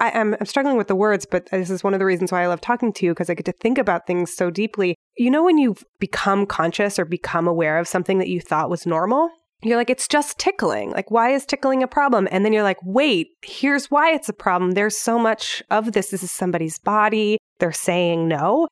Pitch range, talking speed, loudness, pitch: 180-245 Hz, 245 wpm, -20 LUFS, 205 Hz